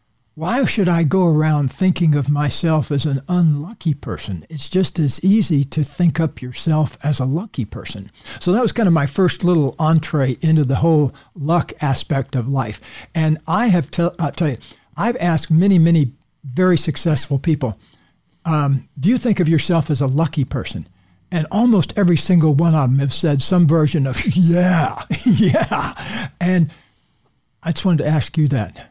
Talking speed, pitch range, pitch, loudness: 175 wpm, 135-175 Hz, 155 Hz, -18 LUFS